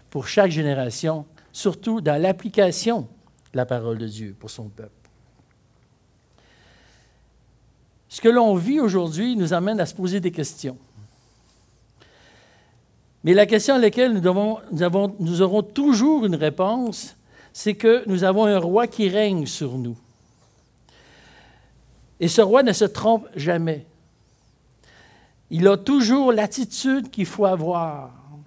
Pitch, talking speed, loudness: 180 Hz, 135 wpm, -20 LUFS